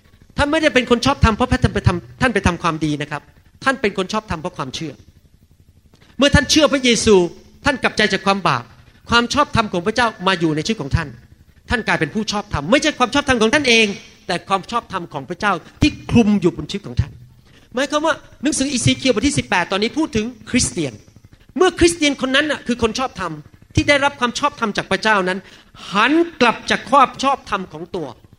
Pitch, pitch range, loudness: 215 Hz, 170-260 Hz, -17 LUFS